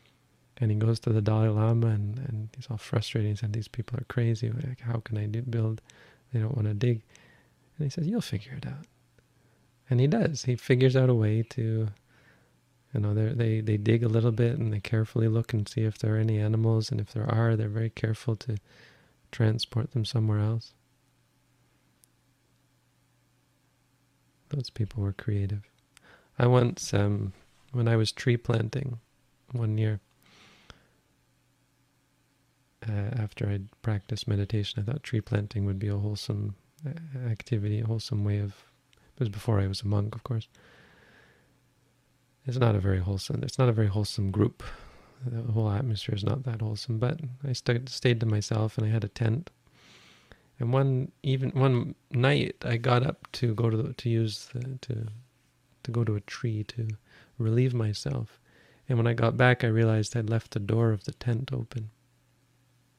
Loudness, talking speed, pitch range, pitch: -29 LUFS, 175 wpm, 110-125 Hz, 115 Hz